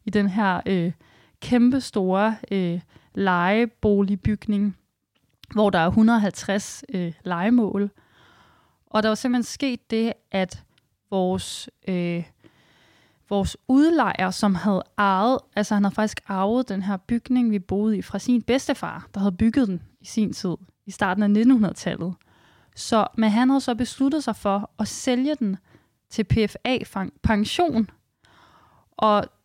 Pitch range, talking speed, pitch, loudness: 195-235 Hz, 135 wpm, 210 Hz, -23 LUFS